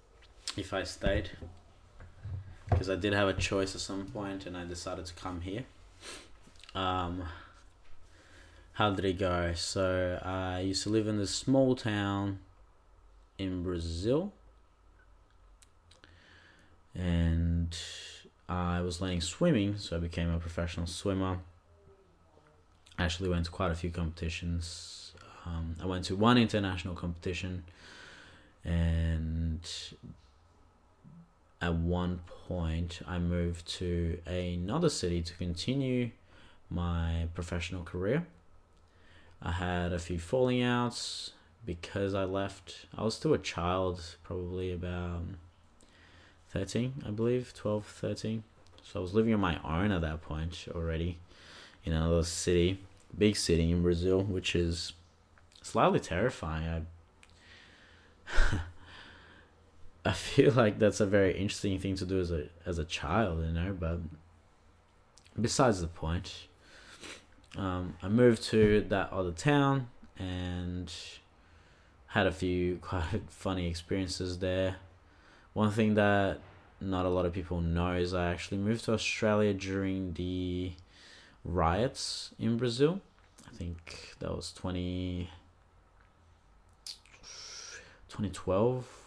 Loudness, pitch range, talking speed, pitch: -33 LUFS, 85-95 Hz, 120 wpm, 90 Hz